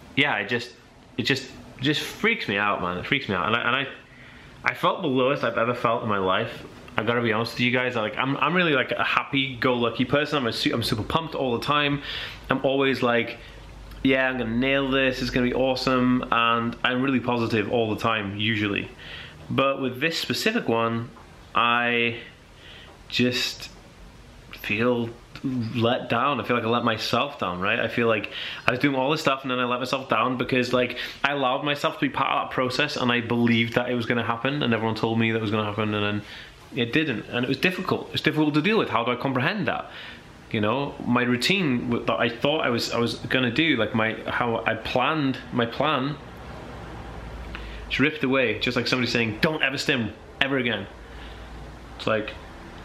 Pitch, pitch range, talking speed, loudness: 120 Hz, 115-135 Hz, 210 wpm, -24 LUFS